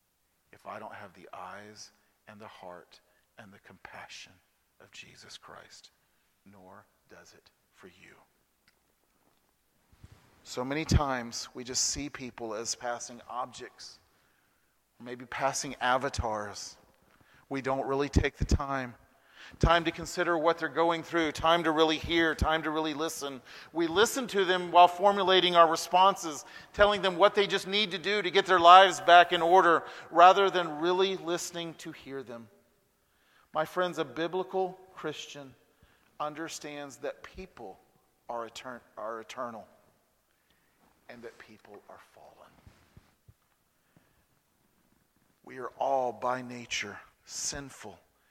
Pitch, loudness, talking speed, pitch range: 160 Hz, -27 LUFS, 130 wpm, 125-180 Hz